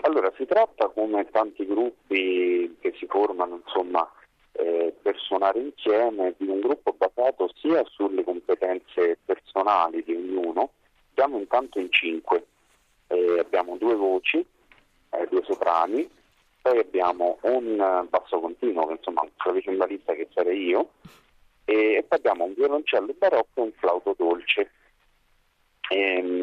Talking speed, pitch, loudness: 135 wpm, 335 Hz, -25 LUFS